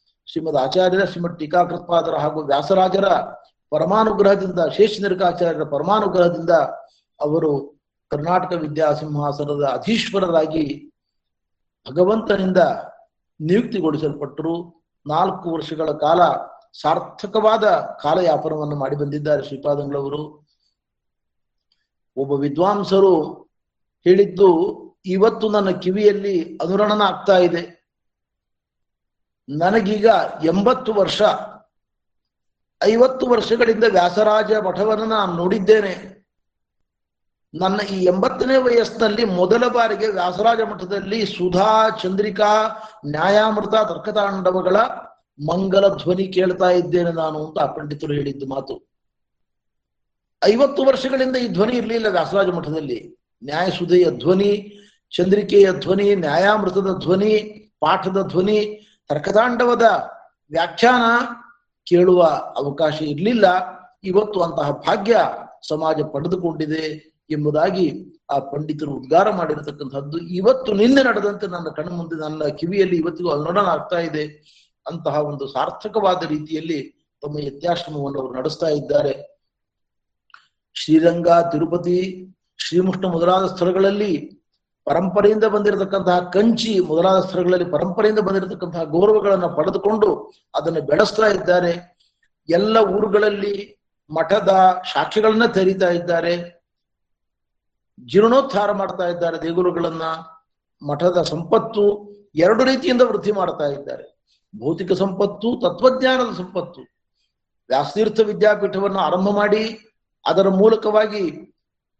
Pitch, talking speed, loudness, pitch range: 185 Hz, 85 wpm, -18 LUFS, 160-210 Hz